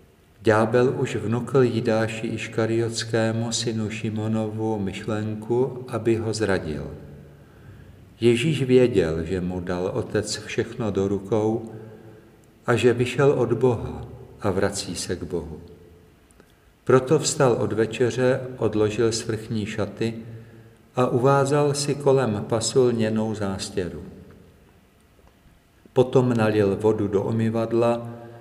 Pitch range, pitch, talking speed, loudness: 100-120 Hz, 110 Hz, 100 wpm, -23 LUFS